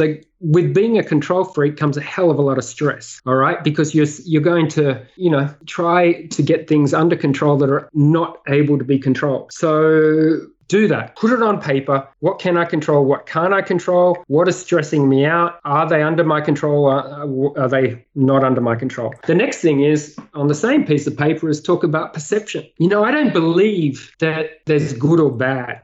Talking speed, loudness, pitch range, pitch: 215 wpm, -17 LUFS, 140-170 Hz, 155 Hz